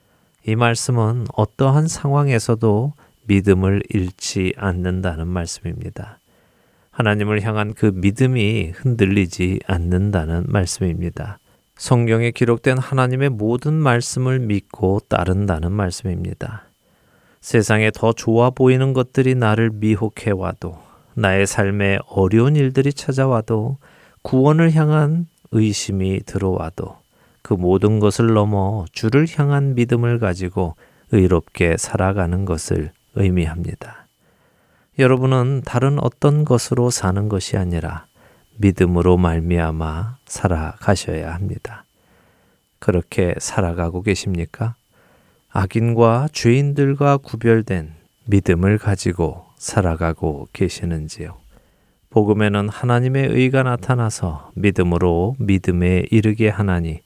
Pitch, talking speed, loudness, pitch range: 105 Hz, 260 characters per minute, -18 LUFS, 90-125 Hz